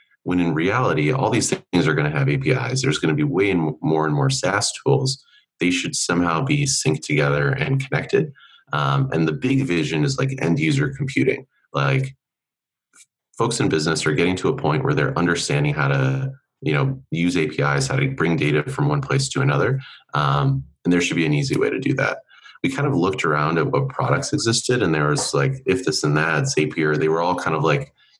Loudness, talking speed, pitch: -20 LUFS, 215 wpm, 130 Hz